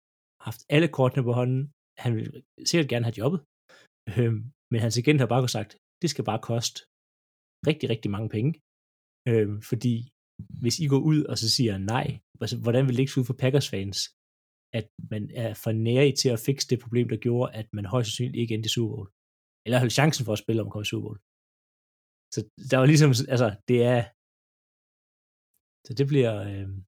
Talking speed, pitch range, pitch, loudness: 190 wpm, 110-130 Hz, 120 Hz, -26 LUFS